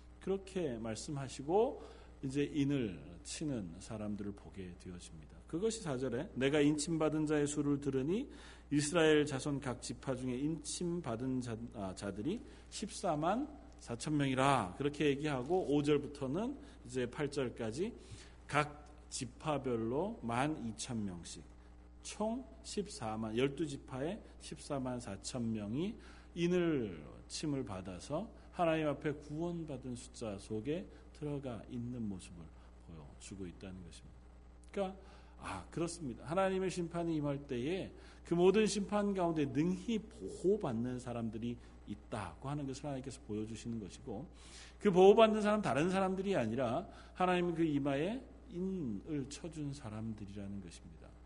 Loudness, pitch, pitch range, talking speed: -37 LUFS, 135 Hz, 105-160 Hz, 275 characters per minute